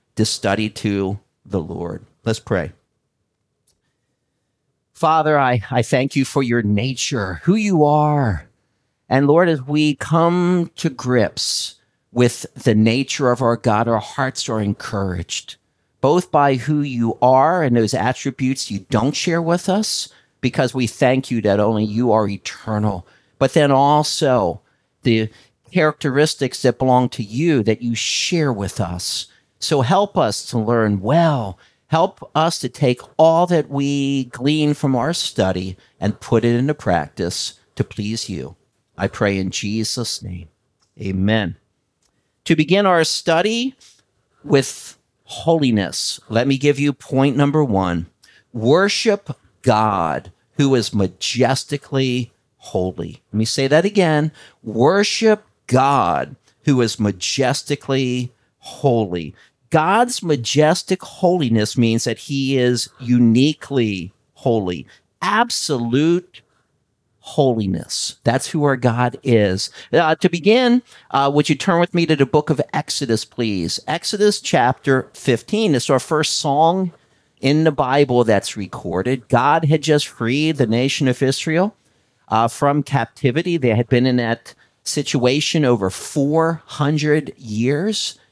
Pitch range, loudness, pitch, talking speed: 115-150 Hz, -18 LUFS, 130 Hz, 130 wpm